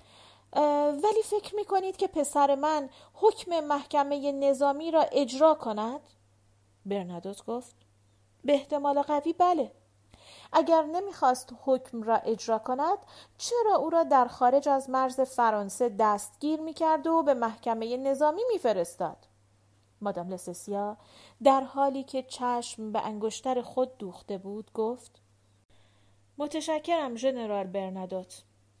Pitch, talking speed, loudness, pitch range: 255 Hz, 115 wpm, -28 LUFS, 200-295 Hz